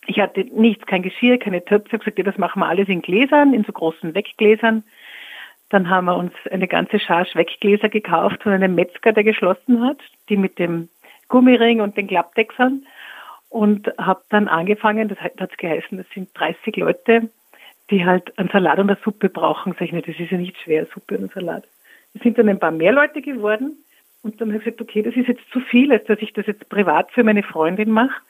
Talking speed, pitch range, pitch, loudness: 215 wpm, 185-230 Hz, 210 Hz, -18 LUFS